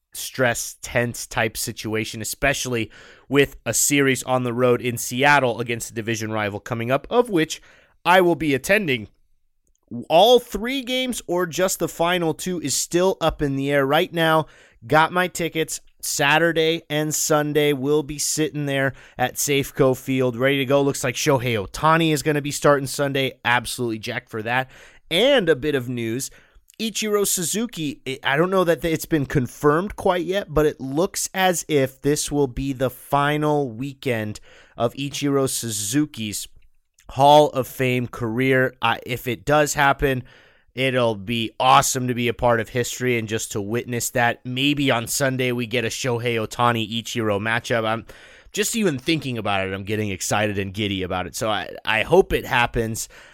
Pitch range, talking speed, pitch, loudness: 120-150 Hz, 170 wpm, 135 Hz, -21 LUFS